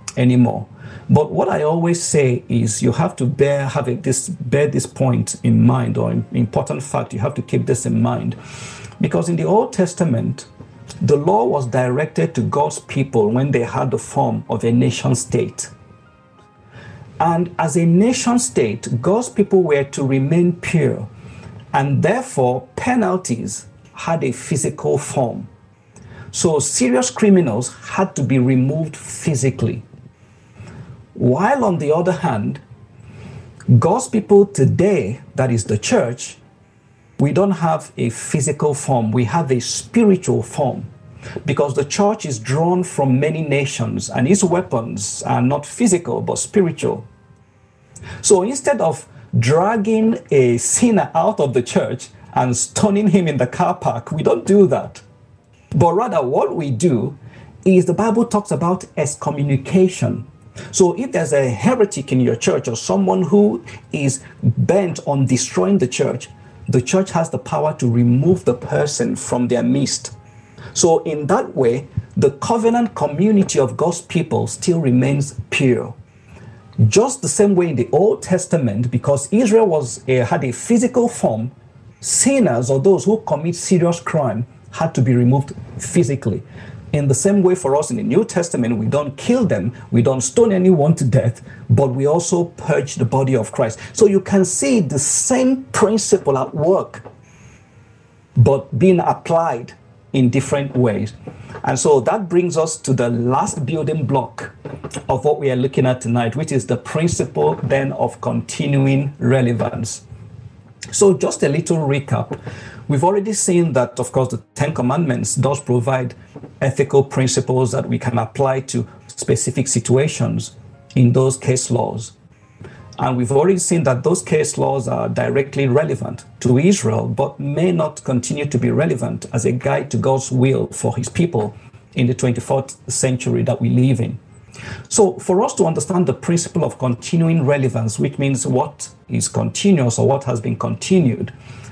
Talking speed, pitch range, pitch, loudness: 155 wpm, 120-170 Hz, 135 Hz, -17 LUFS